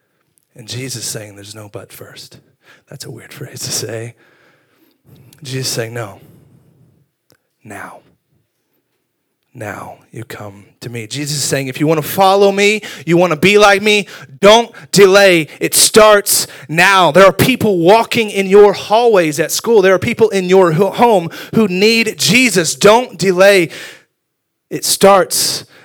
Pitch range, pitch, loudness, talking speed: 140-200 Hz, 175 Hz, -11 LUFS, 150 wpm